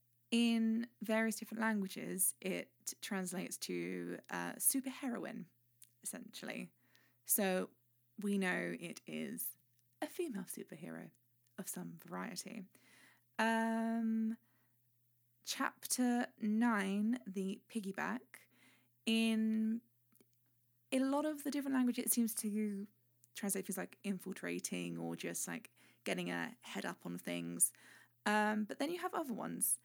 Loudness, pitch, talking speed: -39 LUFS, 195 Hz, 115 wpm